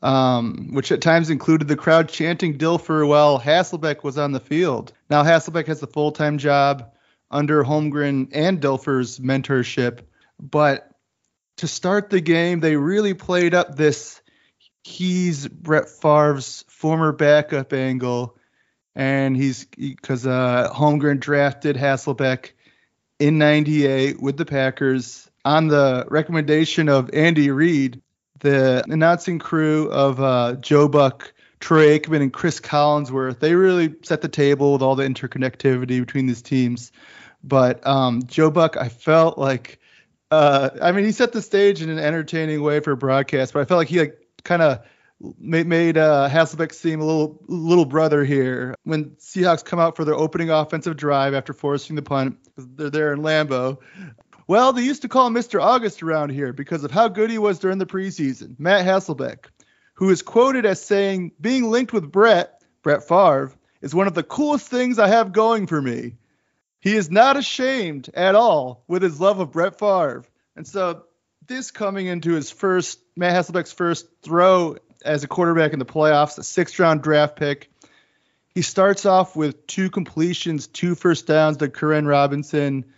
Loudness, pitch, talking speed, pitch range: -19 LUFS, 155 Hz, 165 wpm, 140-175 Hz